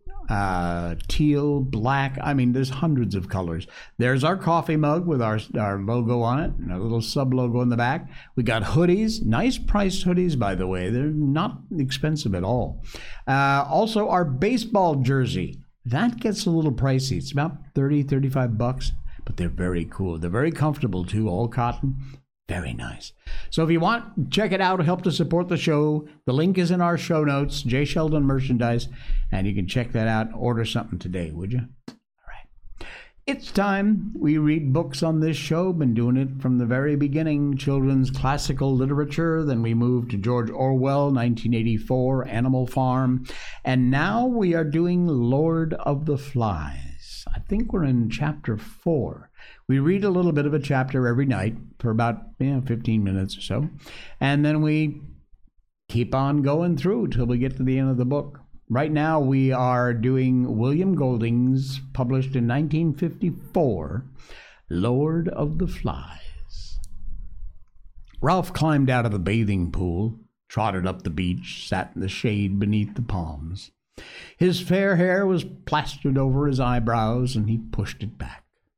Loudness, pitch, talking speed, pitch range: -23 LUFS, 130 Hz, 170 wpm, 115-155 Hz